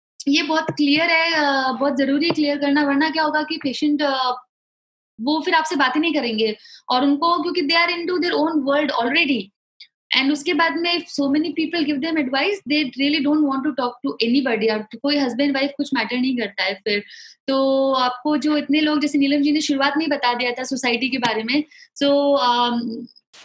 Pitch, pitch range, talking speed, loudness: 285 Hz, 255-305 Hz, 205 wpm, -19 LUFS